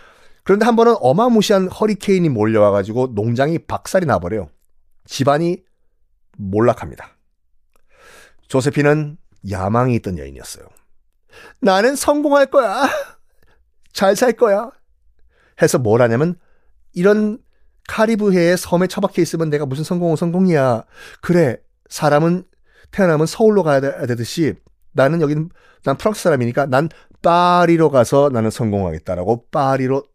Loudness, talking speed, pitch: -16 LUFS, 295 characters per minute, 145 Hz